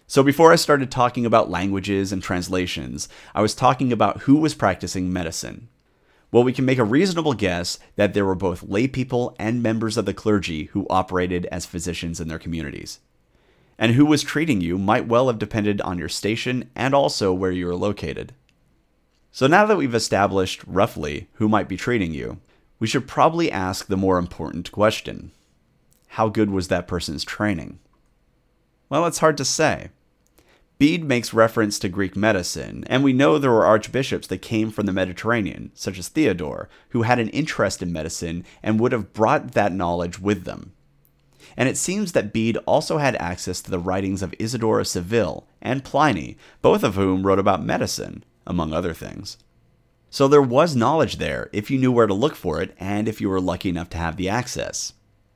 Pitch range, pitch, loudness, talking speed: 90-125 Hz, 105 Hz, -21 LUFS, 185 wpm